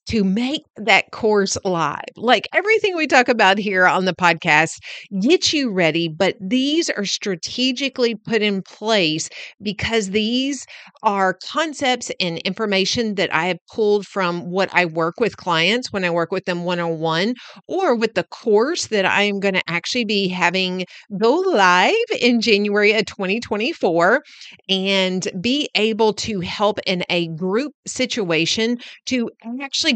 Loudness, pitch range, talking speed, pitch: -19 LUFS, 185-240 Hz, 155 wpm, 205 Hz